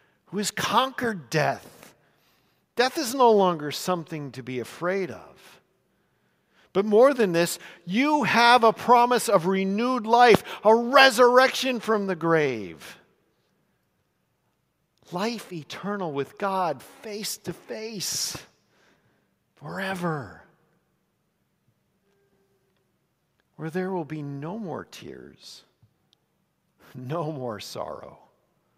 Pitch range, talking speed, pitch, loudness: 155-225 Hz, 100 wpm, 190 Hz, -23 LUFS